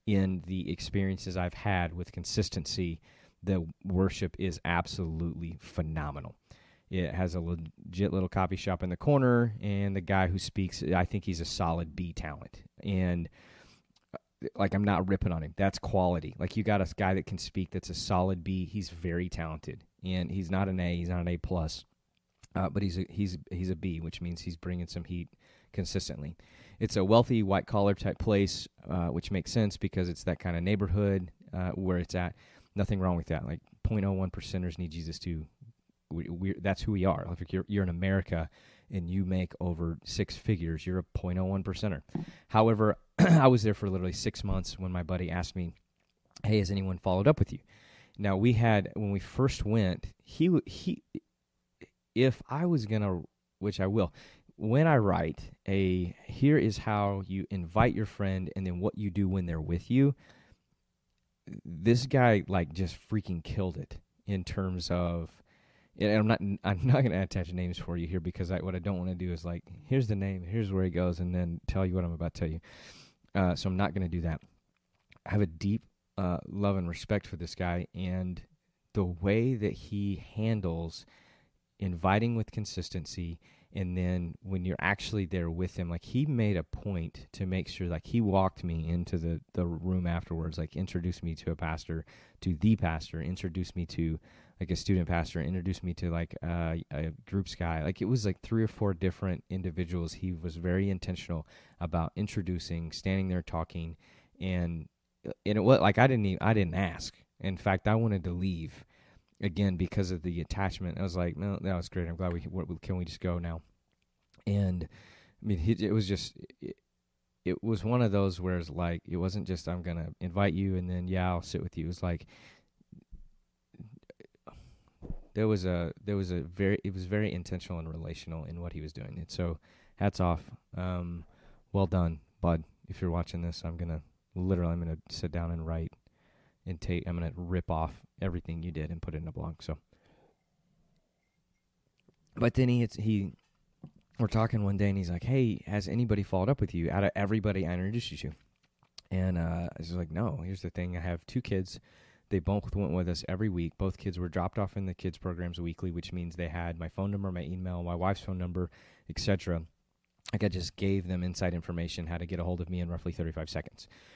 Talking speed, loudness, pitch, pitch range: 200 wpm, -32 LUFS, 90 Hz, 85-100 Hz